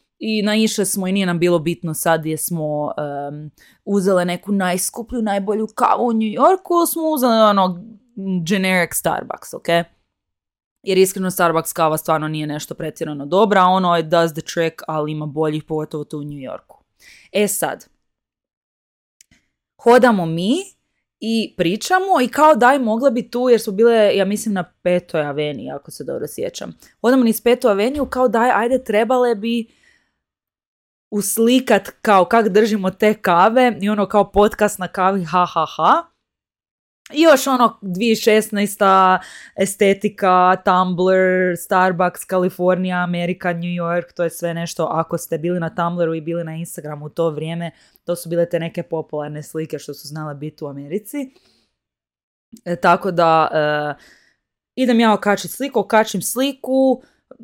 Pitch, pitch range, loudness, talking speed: 185 Hz, 170-220 Hz, -17 LUFS, 155 wpm